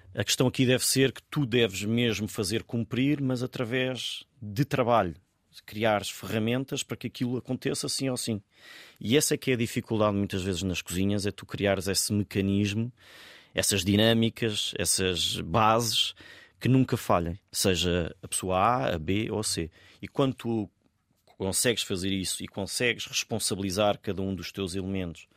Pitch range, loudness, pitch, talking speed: 95-125 Hz, -28 LUFS, 105 Hz, 165 wpm